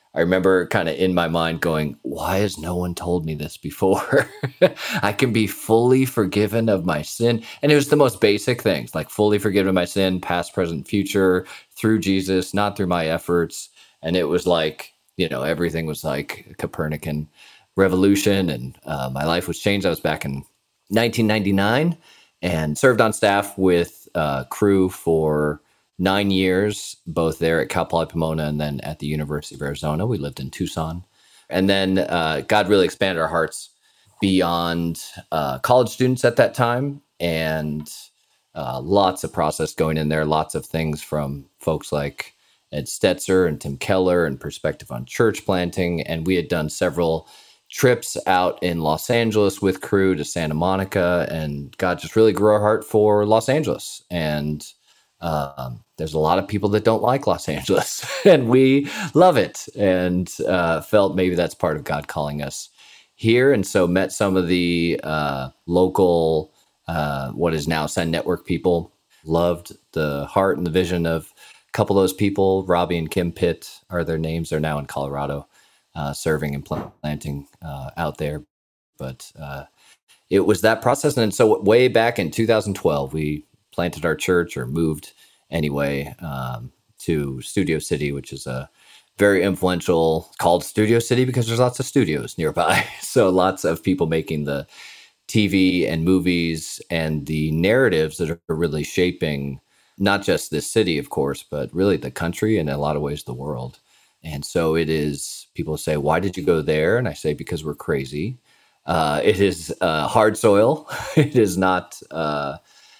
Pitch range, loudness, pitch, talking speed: 75-100 Hz, -21 LUFS, 85 Hz, 175 wpm